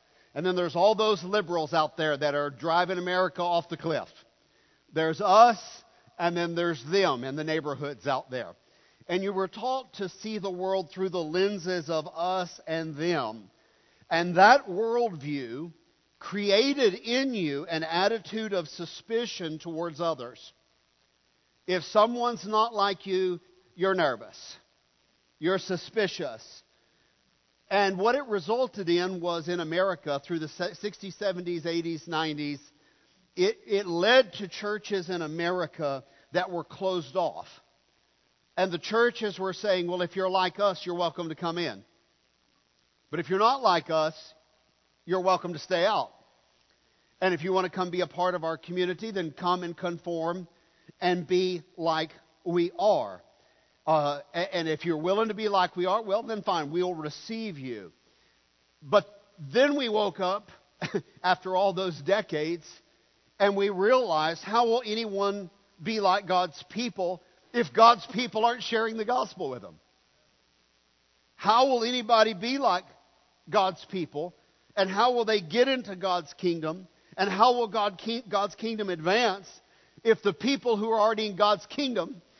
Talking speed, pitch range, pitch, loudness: 155 wpm, 165-205 Hz, 180 Hz, -28 LUFS